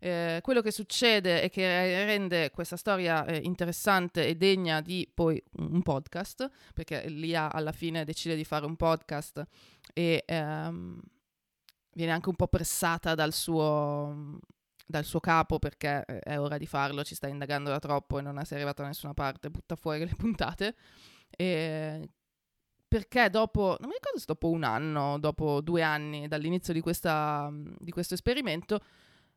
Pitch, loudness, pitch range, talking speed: 160 Hz, -31 LUFS, 150-175 Hz, 160 wpm